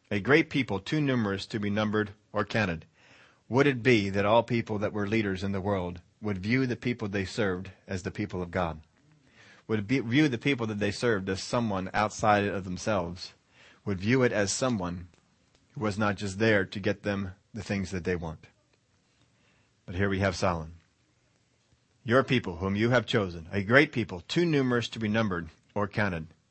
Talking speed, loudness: 195 wpm, -28 LUFS